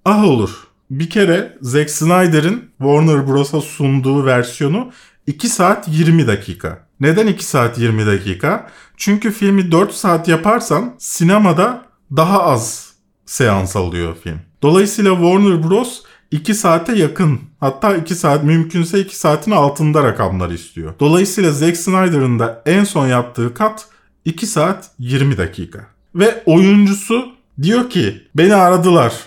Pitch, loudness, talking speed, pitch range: 165 Hz, -14 LUFS, 130 wpm, 135-195 Hz